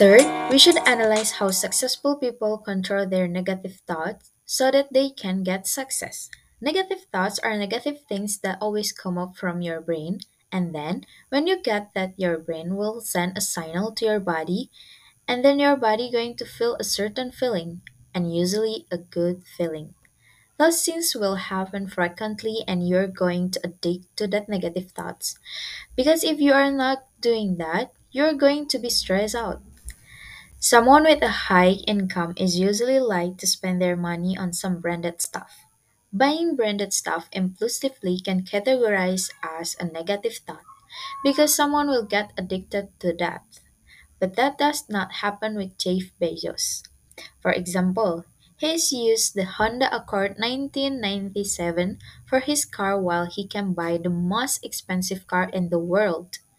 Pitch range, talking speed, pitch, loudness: 180-245 Hz, 160 wpm, 200 Hz, -23 LUFS